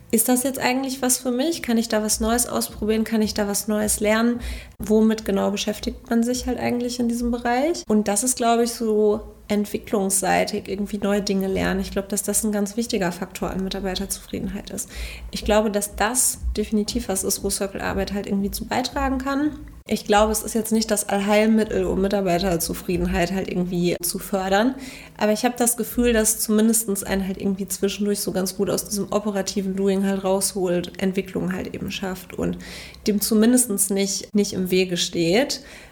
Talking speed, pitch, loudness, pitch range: 185 wpm, 210 Hz, -22 LUFS, 195-225 Hz